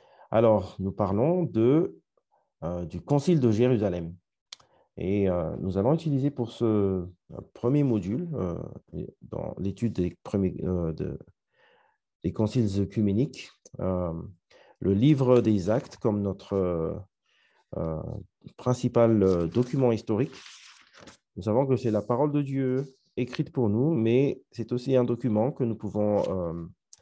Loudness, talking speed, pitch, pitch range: -27 LUFS, 135 wpm, 110 Hz, 95-125 Hz